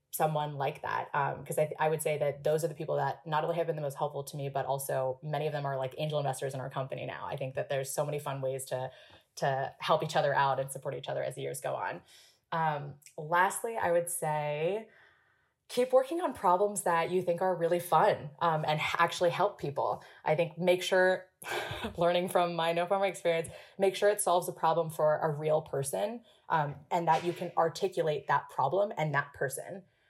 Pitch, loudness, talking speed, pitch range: 160 Hz, -31 LUFS, 220 wpm, 145-180 Hz